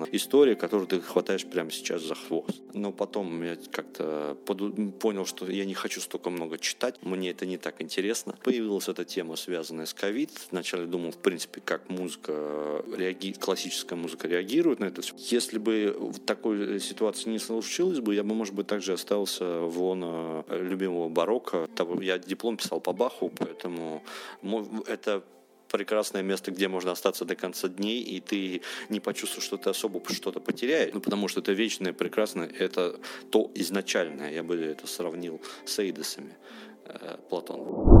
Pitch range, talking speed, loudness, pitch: 85-105 Hz, 160 wpm, -30 LUFS, 95 Hz